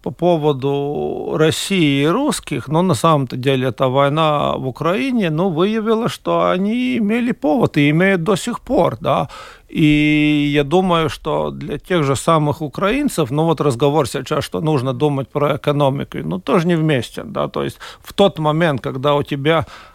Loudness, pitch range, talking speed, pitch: -17 LUFS, 145-175 Hz, 170 wpm, 155 Hz